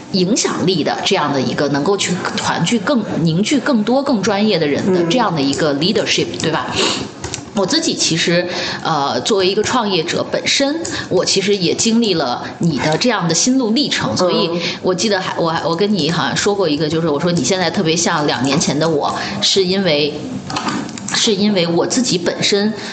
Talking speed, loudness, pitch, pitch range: 300 characters per minute, -16 LUFS, 195 Hz, 170-220 Hz